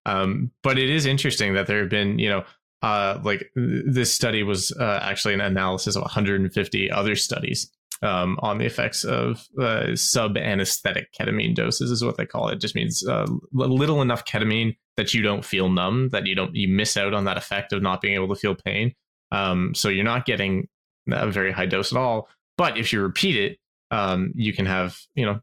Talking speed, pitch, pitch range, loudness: 210 wpm, 105 Hz, 95-120 Hz, -23 LUFS